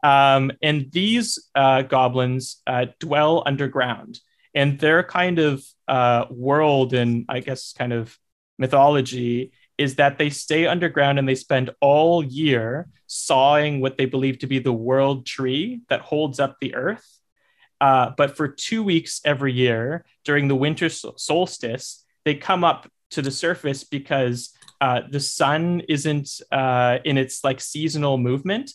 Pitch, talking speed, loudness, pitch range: 140 Hz, 150 wpm, -21 LUFS, 130-150 Hz